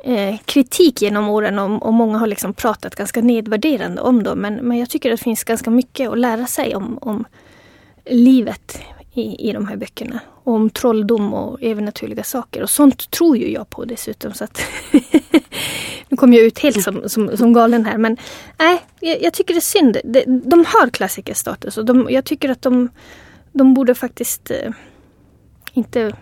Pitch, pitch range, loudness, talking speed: 240 Hz, 220-265 Hz, -16 LUFS, 190 wpm